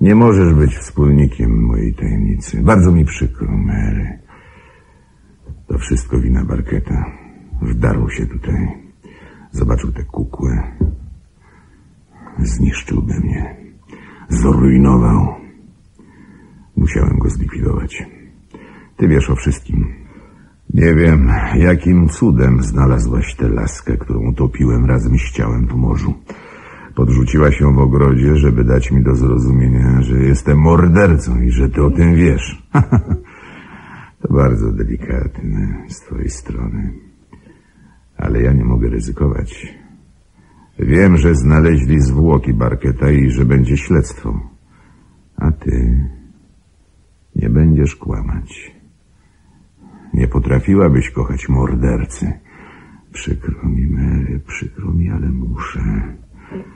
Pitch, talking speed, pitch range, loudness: 70 Hz, 105 wpm, 65-80 Hz, -15 LUFS